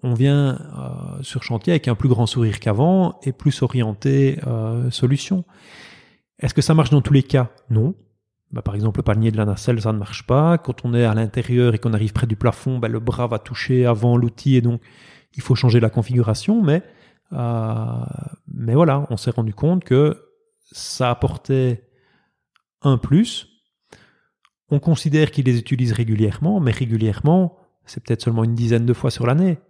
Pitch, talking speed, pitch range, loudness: 125 Hz, 185 wpm, 115-145 Hz, -19 LUFS